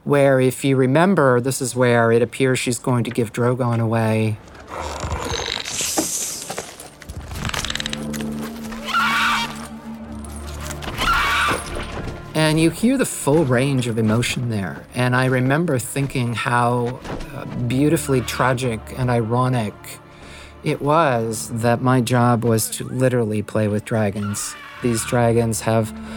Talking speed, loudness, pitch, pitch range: 110 wpm, -20 LUFS, 120 Hz, 110-130 Hz